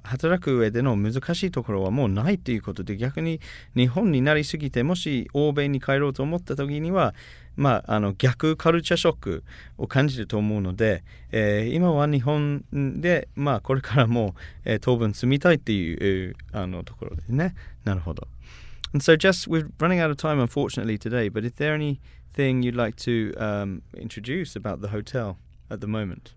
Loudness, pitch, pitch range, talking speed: -24 LUFS, 125 Hz, 105-150 Hz, 505 characters per minute